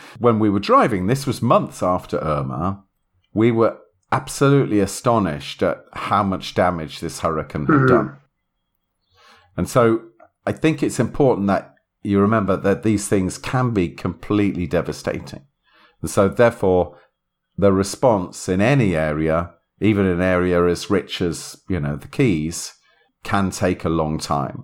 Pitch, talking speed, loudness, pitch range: 95 Hz, 145 wpm, -20 LUFS, 85-105 Hz